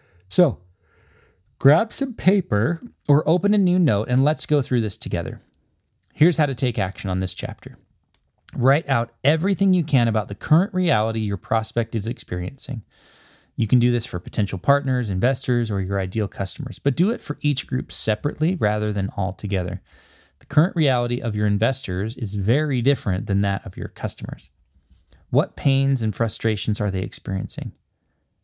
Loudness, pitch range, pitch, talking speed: -22 LUFS, 100-140 Hz, 115 Hz, 170 wpm